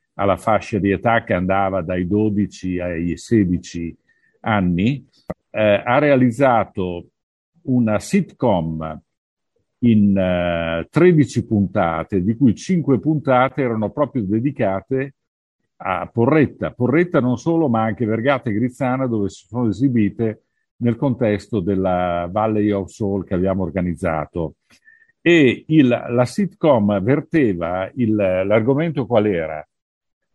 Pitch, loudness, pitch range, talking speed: 110 Hz, -19 LUFS, 95-130 Hz, 115 wpm